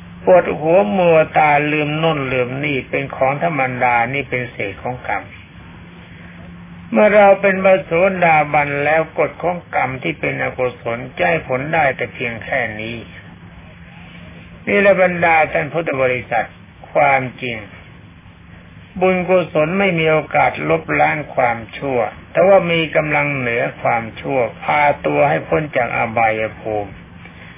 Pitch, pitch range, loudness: 135 Hz, 110-165 Hz, -16 LUFS